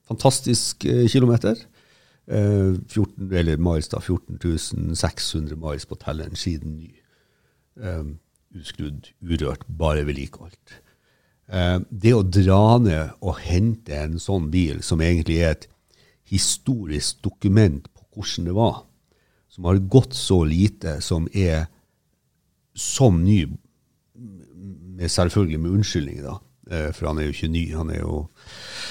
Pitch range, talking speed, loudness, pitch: 80-105 Hz, 125 wpm, -22 LUFS, 90 Hz